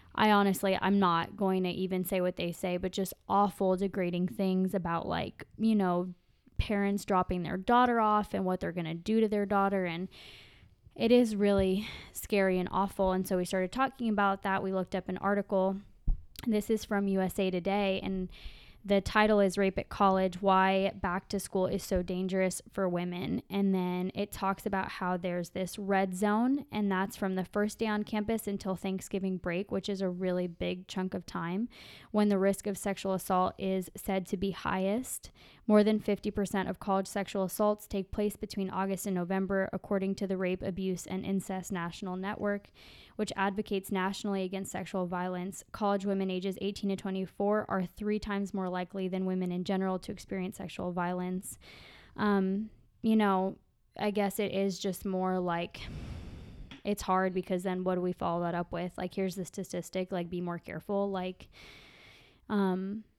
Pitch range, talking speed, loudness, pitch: 185-200 Hz, 180 wpm, -32 LUFS, 190 Hz